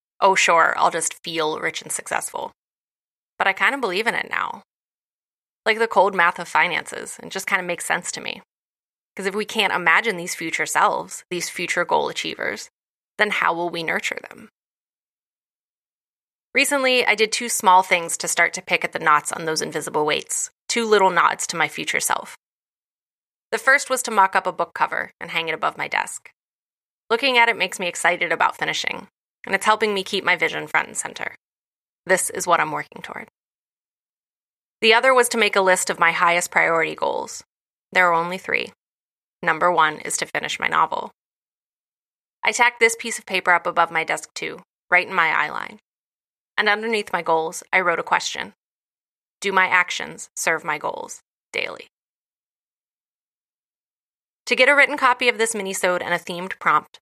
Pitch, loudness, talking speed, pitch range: 195 Hz, -20 LUFS, 185 wpm, 175-235 Hz